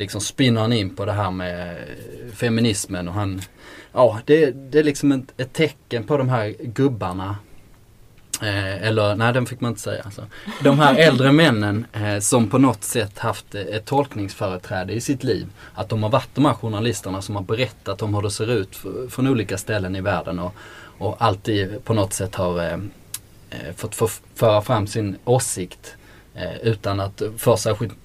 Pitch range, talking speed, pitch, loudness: 100-120 Hz, 180 wpm, 110 Hz, -21 LUFS